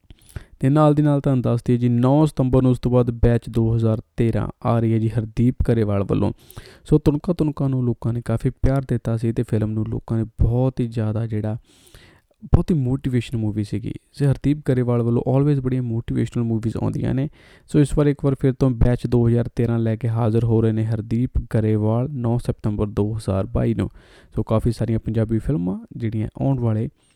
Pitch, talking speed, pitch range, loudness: 120 Hz, 190 wpm, 110-130 Hz, -21 LUFS